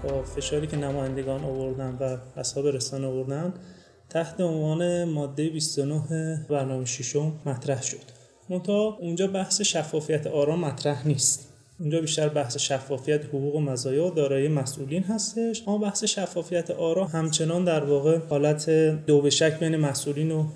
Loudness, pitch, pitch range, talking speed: -26 LUFS, 150 Hz, 140-165 Hz, 140 wpm